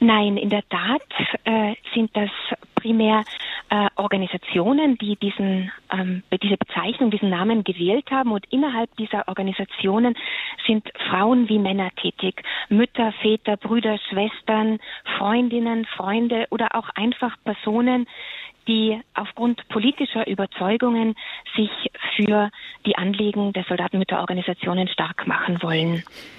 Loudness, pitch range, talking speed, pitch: -22 LUFS, 195-230 Hz, 115 wpm, 215 Hz